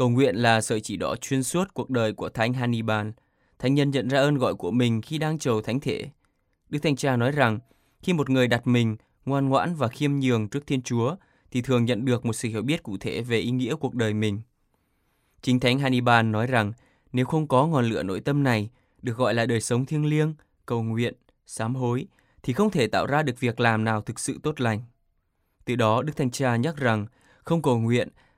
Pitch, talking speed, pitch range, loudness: 125 Hz, 225 wpm, 115-135 Hz, -25 LUFS